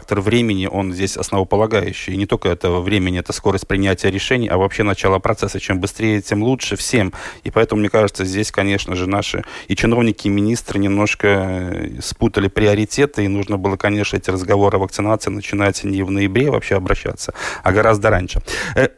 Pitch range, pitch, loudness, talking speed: 95-105 Hz, 100 Hz, -18 LUFS, 175 wpm